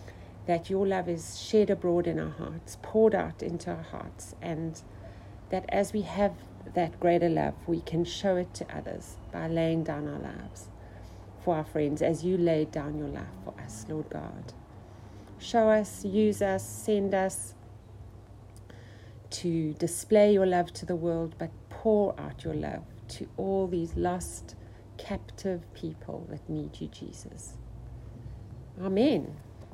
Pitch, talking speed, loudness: 155 Hz, 150 wpm, -30 LUFS